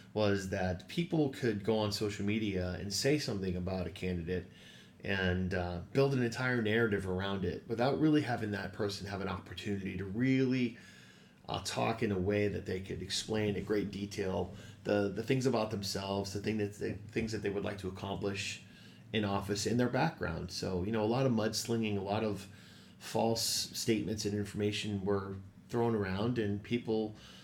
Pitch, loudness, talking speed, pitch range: 105 Hz, -35 LUFS, 185 wpm, 95-110 Hz